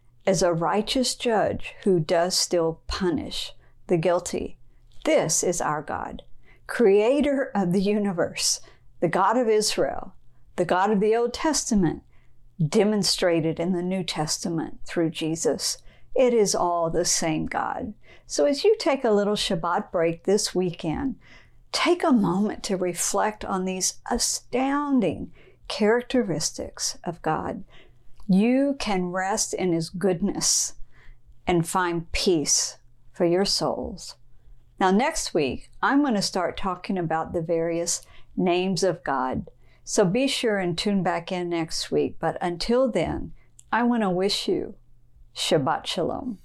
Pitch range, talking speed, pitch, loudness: 170-220 Hz, 140 wpm, 185 Hz, -24 LUFS